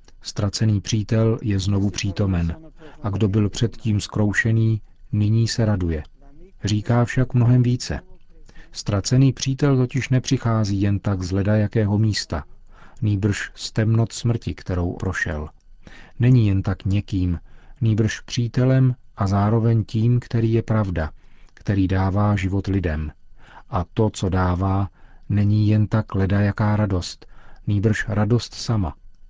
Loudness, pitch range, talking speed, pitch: -21 LUFS, 95-115 Hz, 125 wpm, 105 Hz